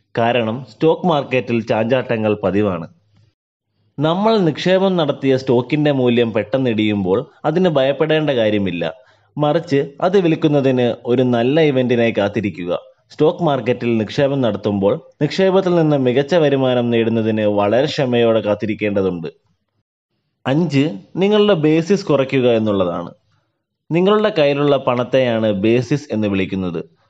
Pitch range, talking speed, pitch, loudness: 110-150 Hz, 100 wpm, 125 Hz, -17 LUFS